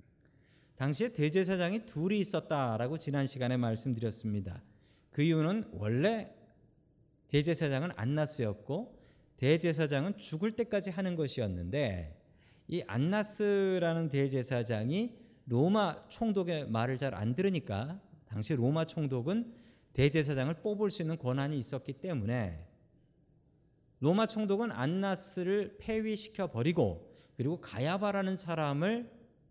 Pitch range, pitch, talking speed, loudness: 125-190 Hz, 155 Hz, 280 characters per minute, -33 LUFS